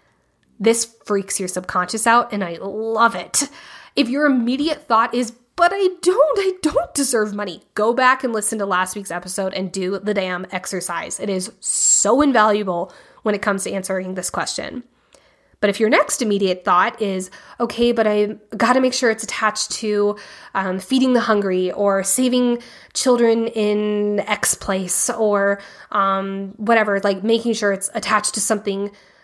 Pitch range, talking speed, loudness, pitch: 195-235 Hz, 165 wpm, -19 LUFS, 210 Hz